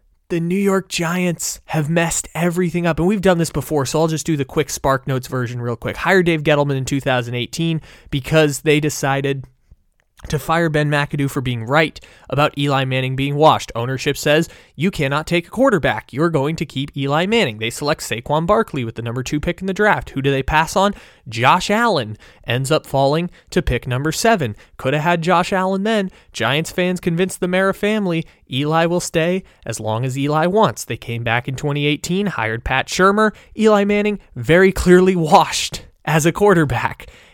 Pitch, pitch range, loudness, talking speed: 155 Hz, 135-180 Hz, -18 LUFS, 190 wpm